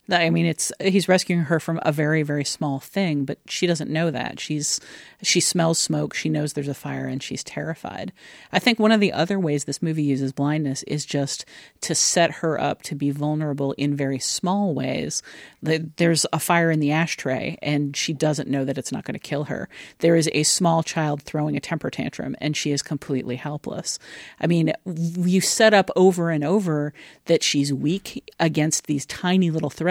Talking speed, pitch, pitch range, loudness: 200 wpm, 155 Hz, 145-170 Hz, -22 LUFS